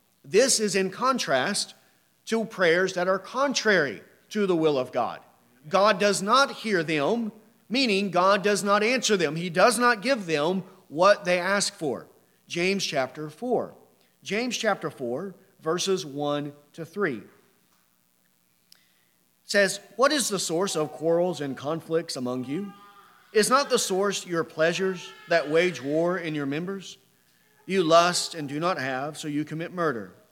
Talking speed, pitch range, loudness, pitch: 150 wpm, 155-205 Hz, -25 LUFS, 185 Hz